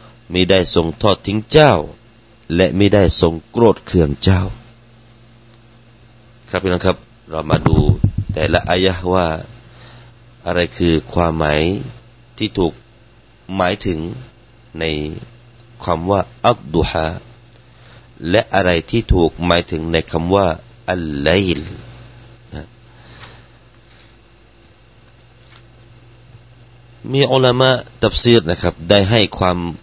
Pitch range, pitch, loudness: 90-120 Hz, 115 Hz, -16 LUFS